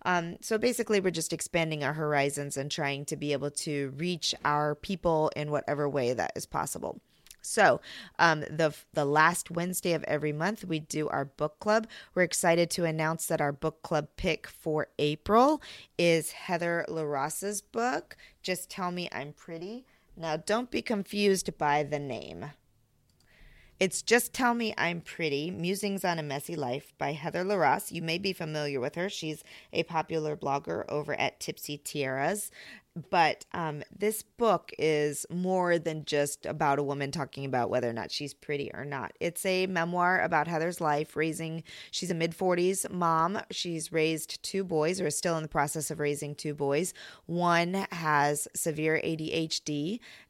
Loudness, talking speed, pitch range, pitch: -30 LUFS, 170 wpm, 150-180 Hz, 160 Hz